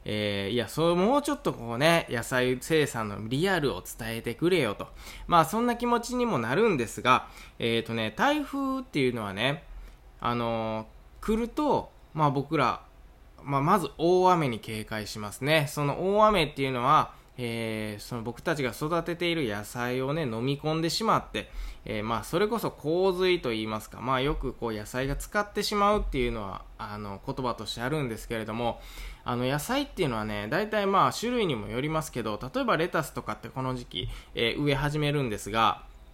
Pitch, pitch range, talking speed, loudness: 135 Hz, 115-170 Hz, 355 characters per minute, -28 LUFS